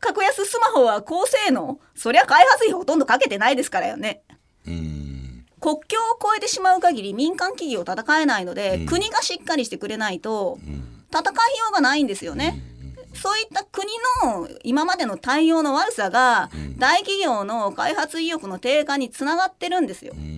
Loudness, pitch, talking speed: -21 LUFS, 305 Hz, 340 characters per minute